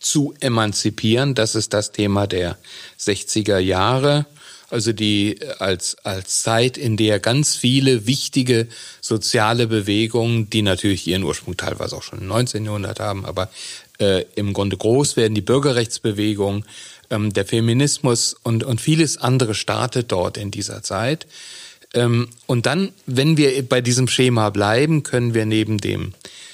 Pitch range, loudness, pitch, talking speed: 105-125 Hz, -19 LUFS, 115 Hz, 145 wpm